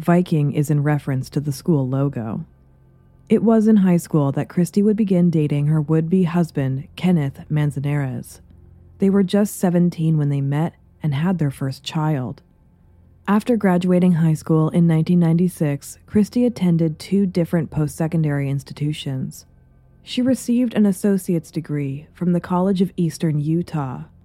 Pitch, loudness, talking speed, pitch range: 160 Hz, -20 LUFS, 150 wpm, 140-180 Hz